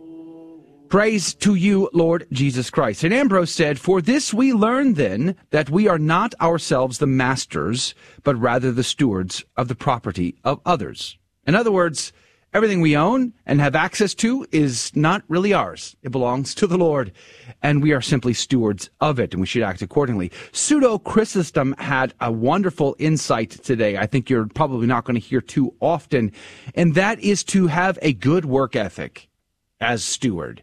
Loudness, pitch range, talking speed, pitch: -20 LUFS, 125-185 Hz, 175 wpm, 150 Hz